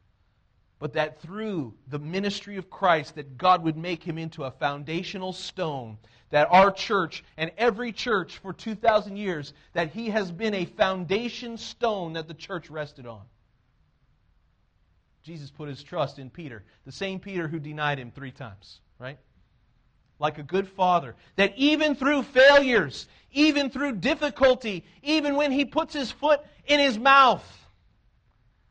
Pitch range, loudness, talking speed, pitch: 130-220 Hz, -25 LUFS, 150 wpm, 165 Hz